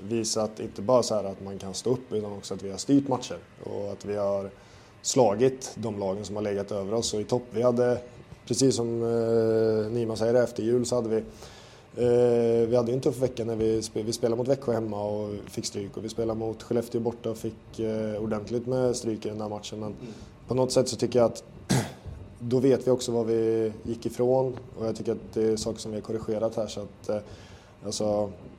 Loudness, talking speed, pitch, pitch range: -28 LUFS, 215 wpm, 115 Hz, 105-120 Hz